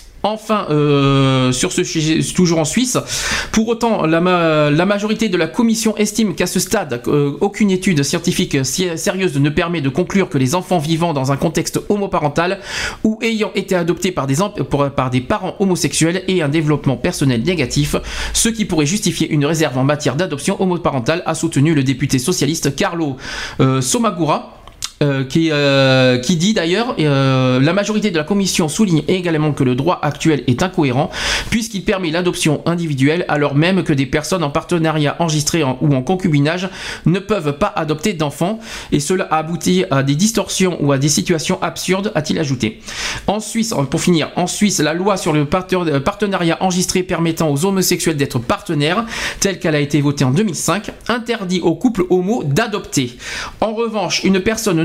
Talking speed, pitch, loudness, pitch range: 175 wpm, 170 Hz, -16 LUFS, 145-195 Hz